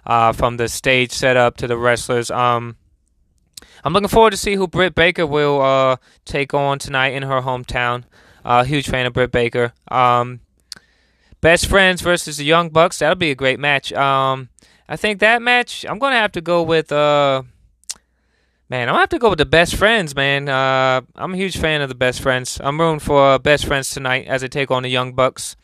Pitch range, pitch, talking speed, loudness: 125-160 Hz, 135 Hz, 215 wpm, -16 LUFS